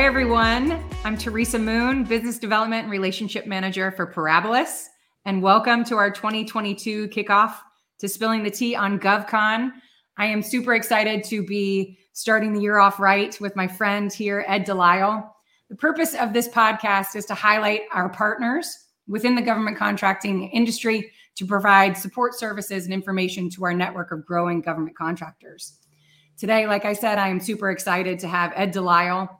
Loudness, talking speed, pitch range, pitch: -22 LUFS, 165 wpm, 190-225 Hz, 205 Hz